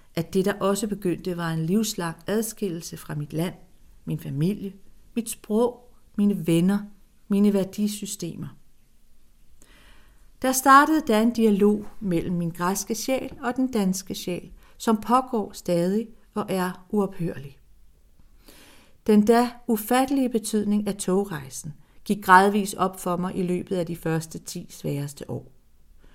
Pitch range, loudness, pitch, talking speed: 170-215 Hz, -24 LUFS, 195 Hz, 135 wpm